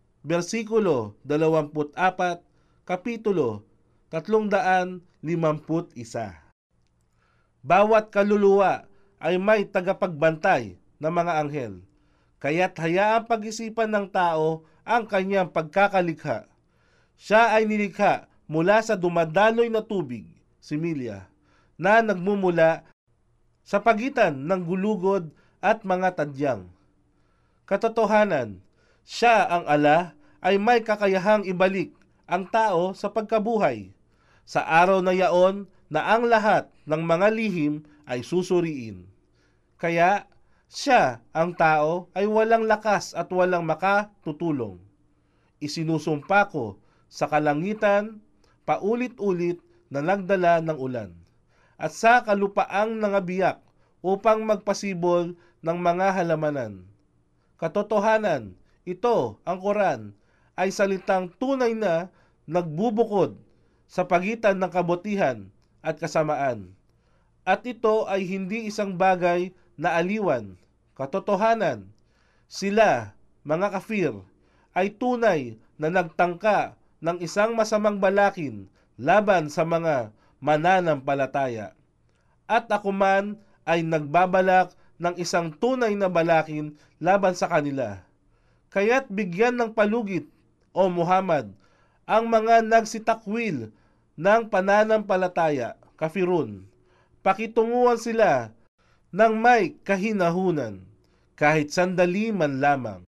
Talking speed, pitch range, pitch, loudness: 95 wpm, 150-205 Hz, 180 Hz, -23 LUFS